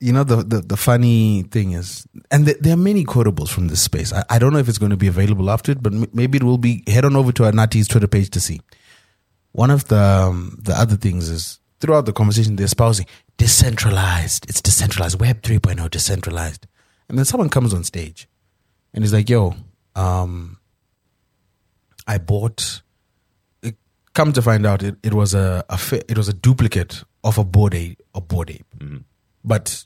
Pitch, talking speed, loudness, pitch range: 105 Hz, 195 wpm, -17 LUFS, 95-115 Hz